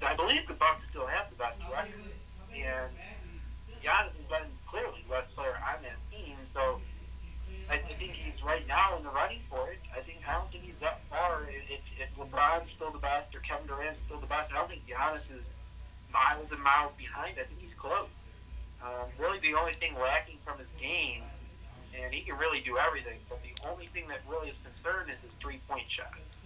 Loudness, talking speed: -34 LUFS, 205 wpm